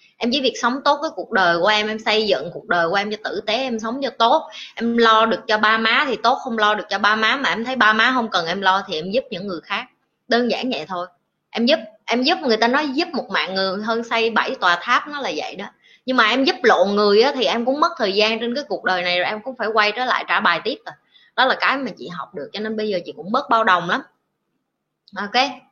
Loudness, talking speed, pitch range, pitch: -19 LUFS, 290 wpm, 205-255 Hz, 225 Hz